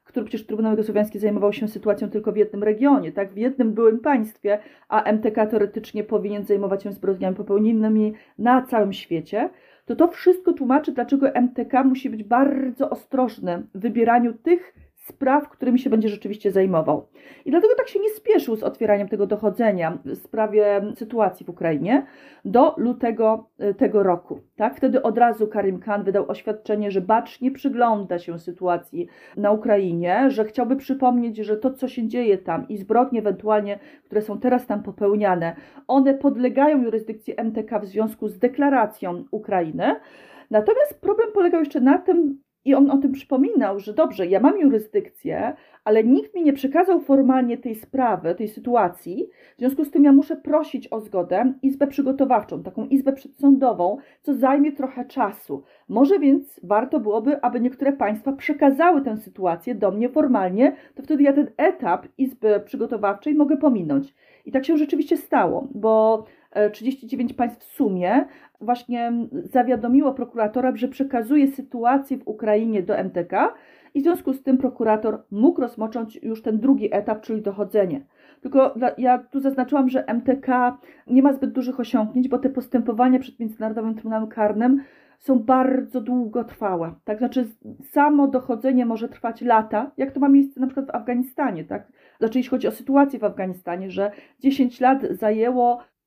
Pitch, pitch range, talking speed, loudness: 245 Hz, 215-275 Hz, 160 wpm, -21 LUFS